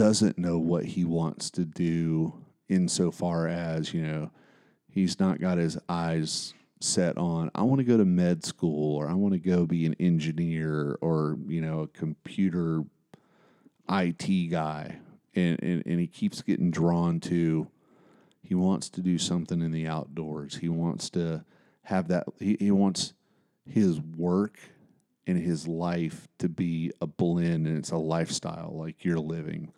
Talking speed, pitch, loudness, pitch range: 160 wpm, 85 Hz, -28 LUFS, 80-90 Hz